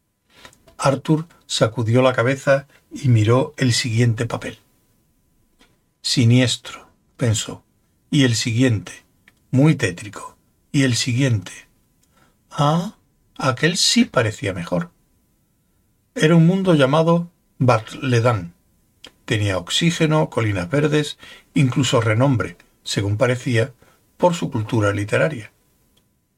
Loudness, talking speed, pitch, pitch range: -19 LUFS, 95 wpm, 130 Hz, 115-145 Hz